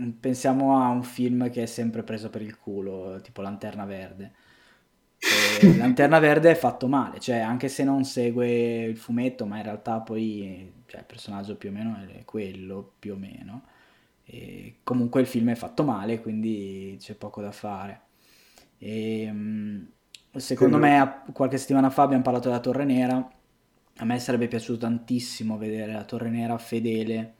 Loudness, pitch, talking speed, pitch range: -24 LUFS, 115 Hz, 165 wpm, 105-125 Hz